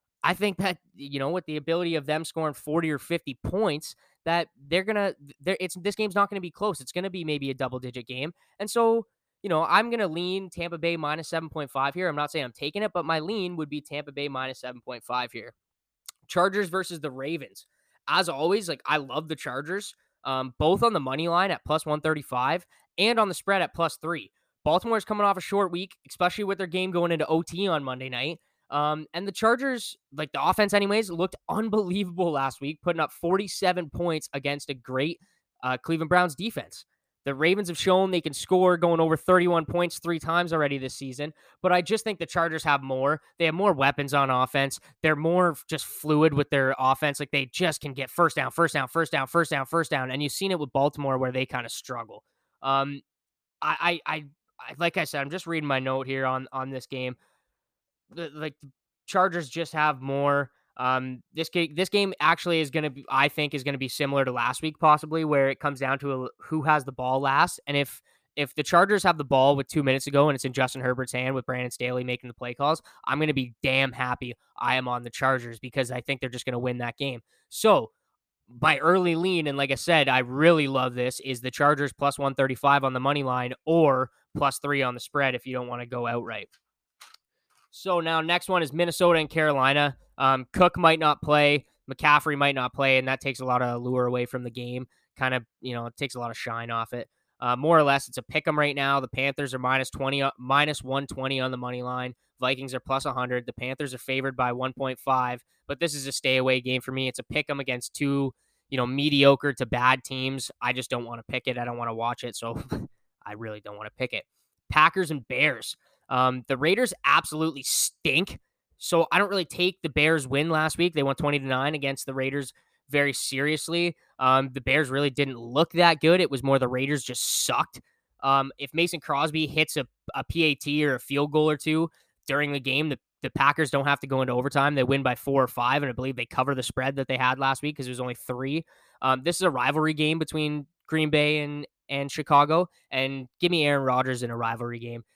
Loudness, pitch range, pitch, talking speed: -26 LUFS, 130-165 Hz, 145 Hz, 230 wpm